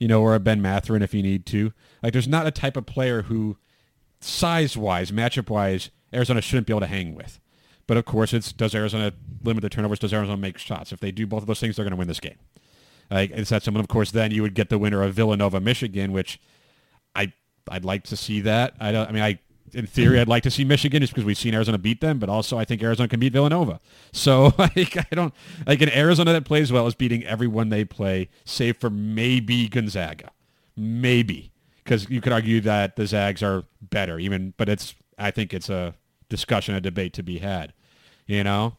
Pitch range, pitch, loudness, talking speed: 100-125 Hz, 110 Hz, -23 LUFS, 230 wpm